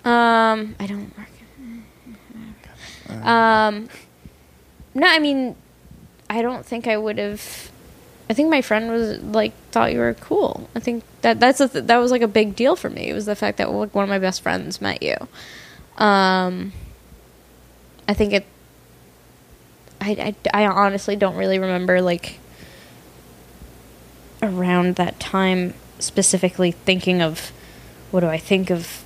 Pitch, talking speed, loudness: 195 Hz, 155 wpm, -20 LUFS